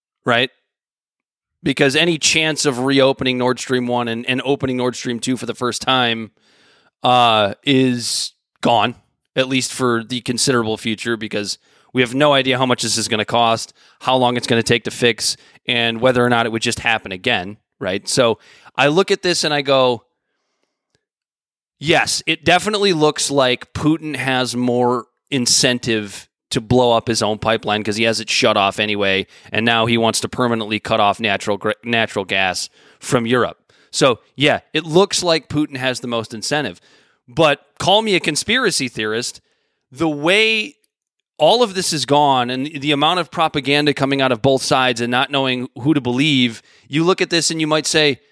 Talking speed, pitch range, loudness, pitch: 180 wpm, 115-145 Hz, -17 LUFS, 125 Hz